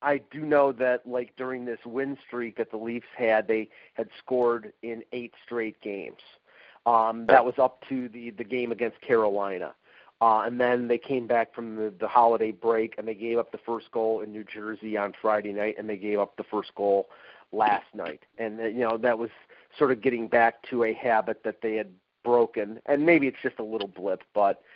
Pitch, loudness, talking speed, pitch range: 115 Hz, -27 LUFS, 210 wpm, 110-125 Hz